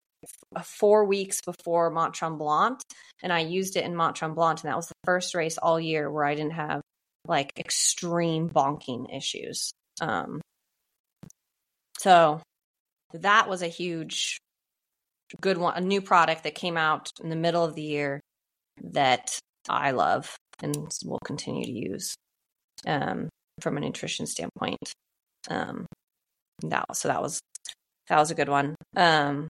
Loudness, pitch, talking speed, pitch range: -27 LUFS, 165 Hz, 145 wpm, 155-175 Hz